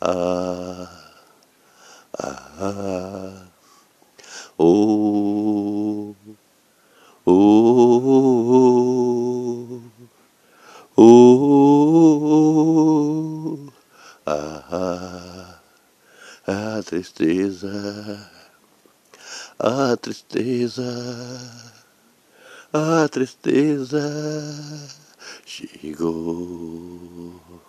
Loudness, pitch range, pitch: -18 LUFS, 95-135 Hz, 115 Hz